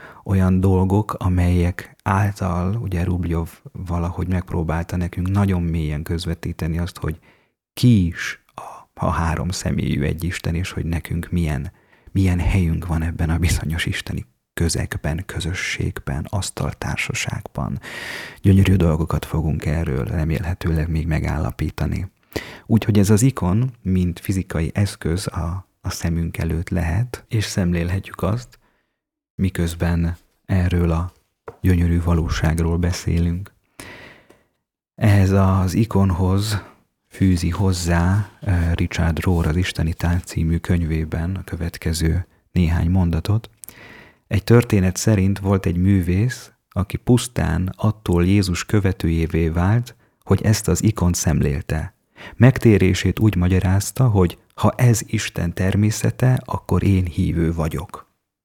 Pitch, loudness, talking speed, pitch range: 90 Hz, -20 LUFS, 110 wpm, 85-100 Hz